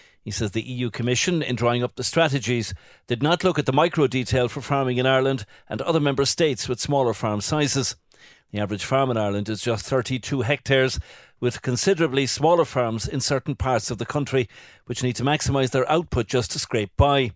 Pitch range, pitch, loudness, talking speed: 120-140 Hz, 130 Hz, -23 LUFS, 200 wpm